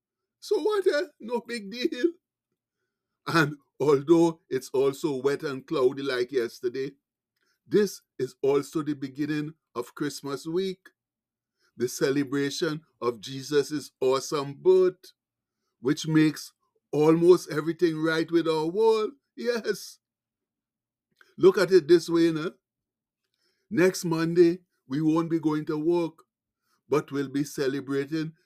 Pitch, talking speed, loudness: 170 Hz, 120 wpm, -26 LUFS